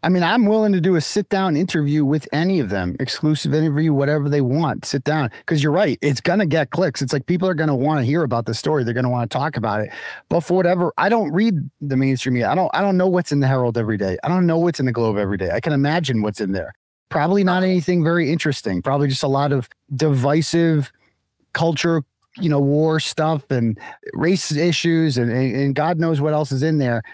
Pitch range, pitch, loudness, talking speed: 135-170 Hz, 150 Hz, -19 LUFS, 240 wpm